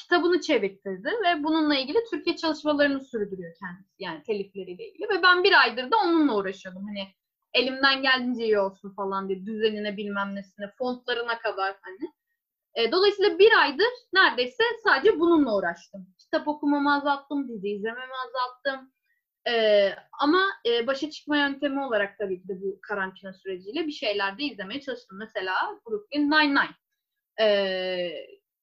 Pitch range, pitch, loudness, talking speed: 200-335 Hz, 265 Hz, -25 LUFS, 135 wpm